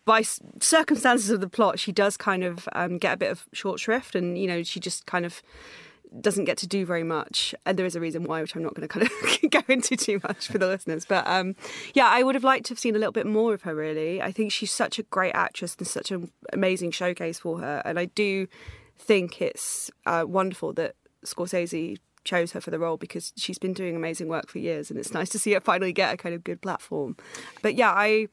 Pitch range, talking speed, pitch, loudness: 175-220 Hz, 250 wpm, 190 Hz, -26 LUFS